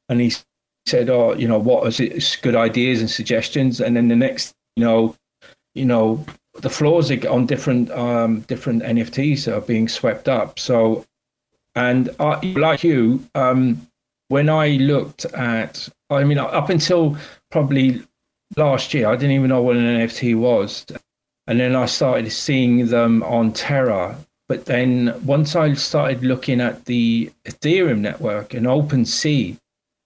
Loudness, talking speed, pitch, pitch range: -18 LUFS, 160 wpm, 125 Hz, 115-145 Hz